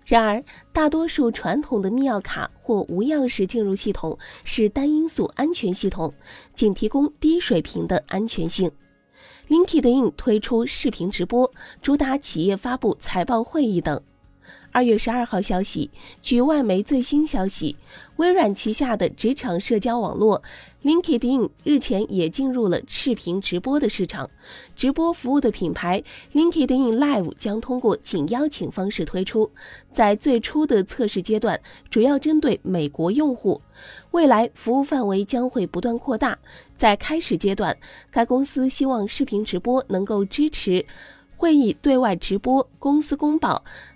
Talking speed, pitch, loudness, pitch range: 260 characters per minute, 235 Hz, -22 LUFS, 200-280 Hz